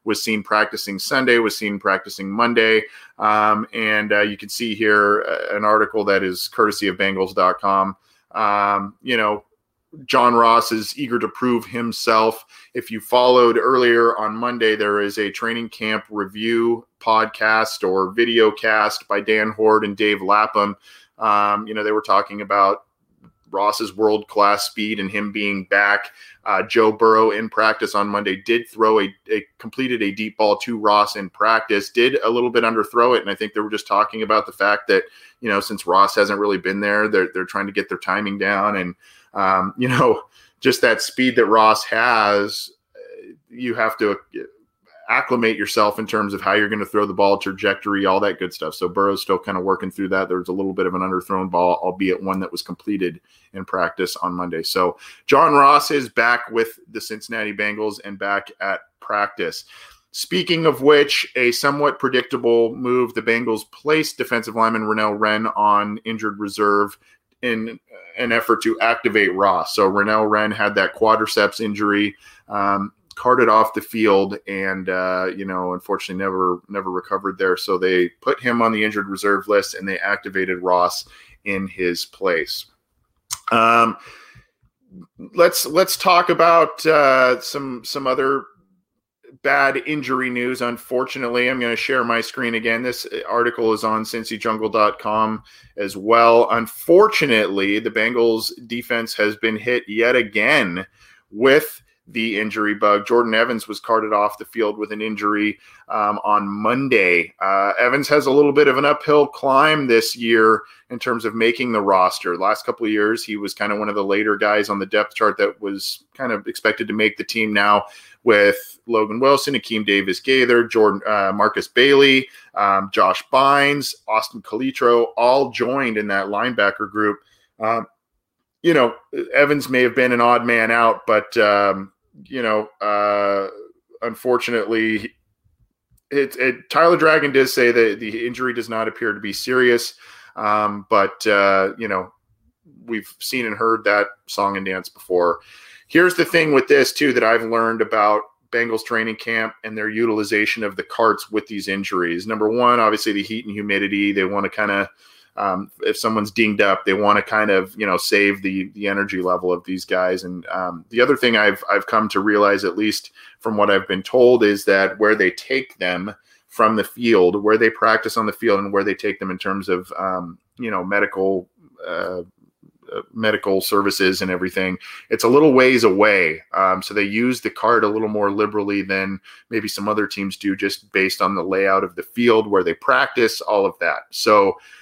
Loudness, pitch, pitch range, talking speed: -18 LUFS, 105 Hz, 100-115 Hz, 180 wpm